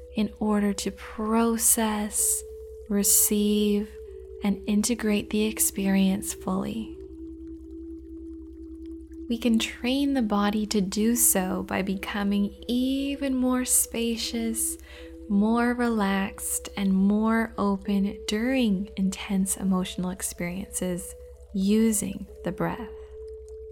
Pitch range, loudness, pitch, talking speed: 200-275 Hz, -25 LUFS, 215 Hz, 90 wpm